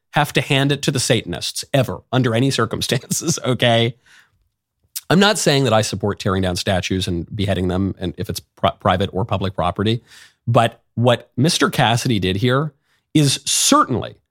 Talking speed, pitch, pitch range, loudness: 170 wpm, 115 Hz, 95-135 Hz, -18 LUFS